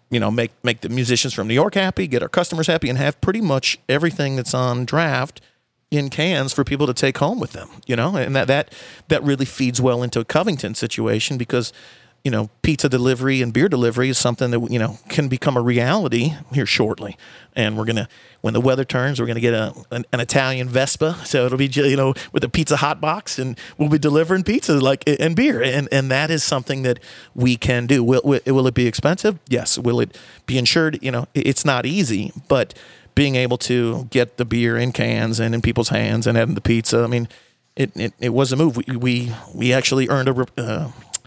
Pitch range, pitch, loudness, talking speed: 120-145 Hz, 130 Hz, -19 LUFS, 220 wpm